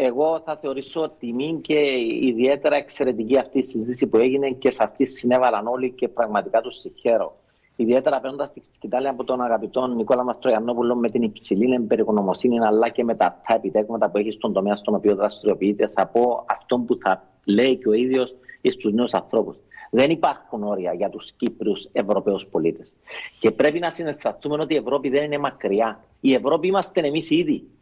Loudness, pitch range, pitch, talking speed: -22 LUFS, 115-140 Hz, 125 Hz, 175 wpm